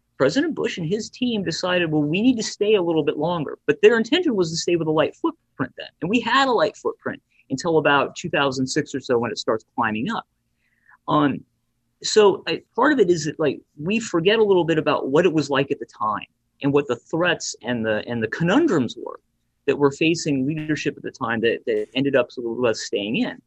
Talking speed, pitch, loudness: 225 wpm, 175 Hz, -21 LUFS